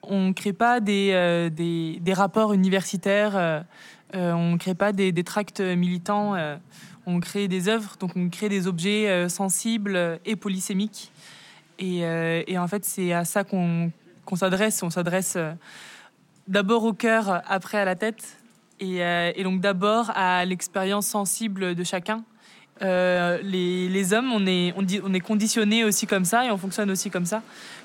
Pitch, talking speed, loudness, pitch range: 190 Hz, 185 wpm, -24 LUFS, 180-210 Hz